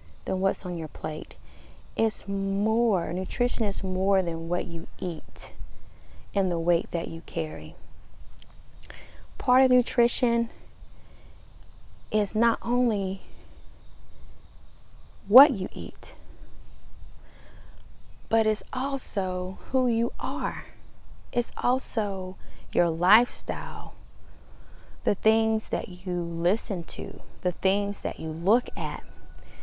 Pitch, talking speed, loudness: 185 Hz, 105 wpm, -27 LUFS